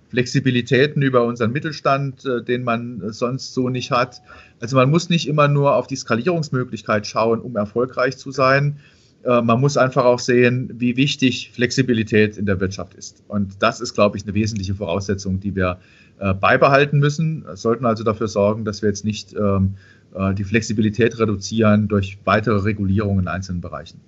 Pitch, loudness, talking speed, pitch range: 115 Hz, -19 LUFS, 165 wpm, 105-130 Hz